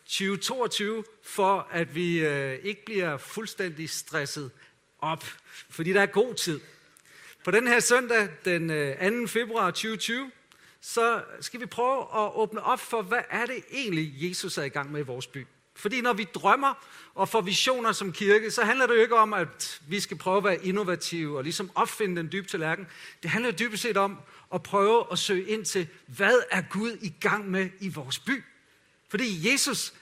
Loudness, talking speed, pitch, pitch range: -27 LUFS, 185 wpm, 200 Hz, 170-225 Hz